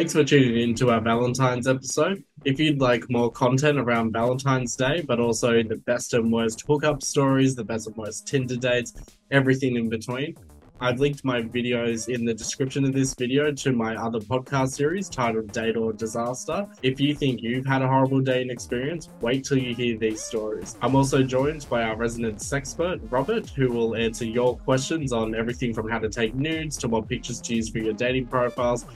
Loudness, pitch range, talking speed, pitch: -24 LUFS, 115-135 Hz, 200 wpm, 125 Hz